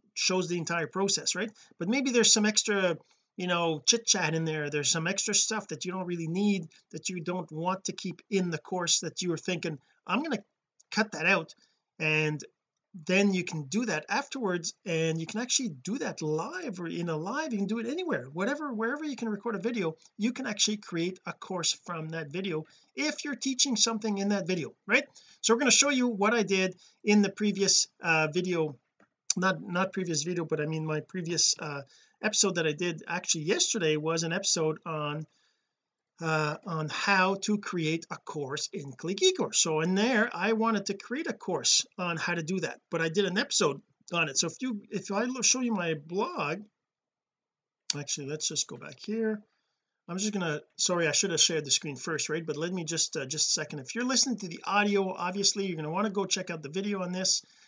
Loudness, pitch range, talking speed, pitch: -29 LUFS, 160-215 Hz, 215 wpm, 185 Hz